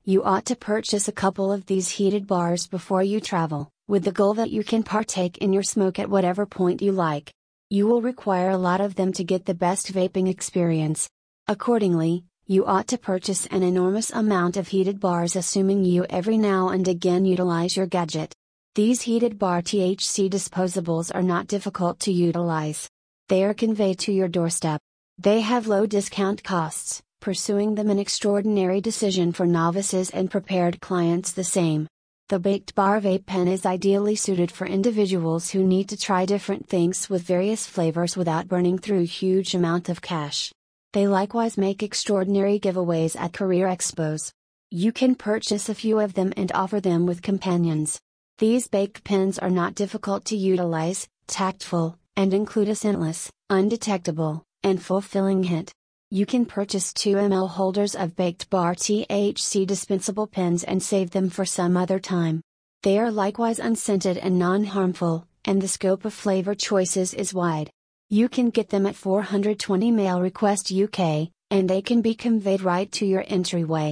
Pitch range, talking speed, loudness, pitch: 180-205 Hz, 170 wpm, -23 LUFS, 190 Hz